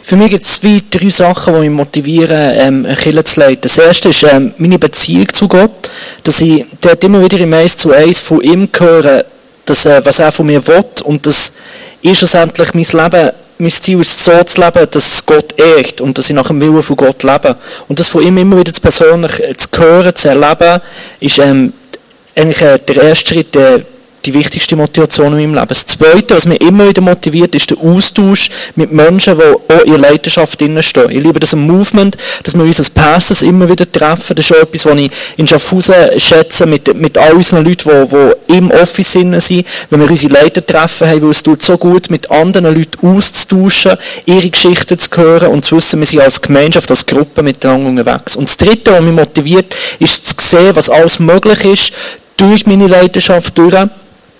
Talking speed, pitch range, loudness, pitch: 210 wpm, 155-185 Hz, -5 LUFS, 165 Hz